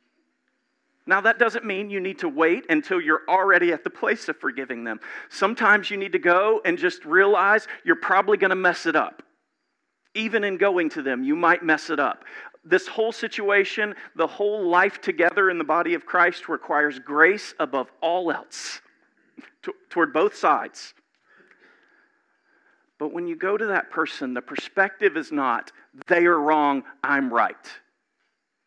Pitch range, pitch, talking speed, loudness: 175-230 Hz, 195 Hz, 165 wpm, -22 LUFS